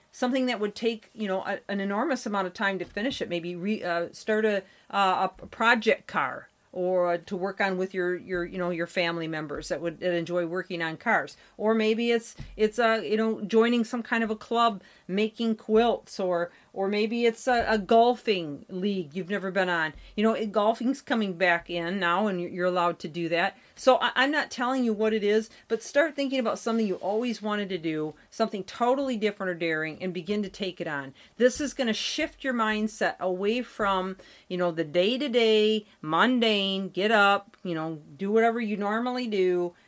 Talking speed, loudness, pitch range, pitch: 210 wpm, -27 LUFS, 180-230 Hz, 205 Hz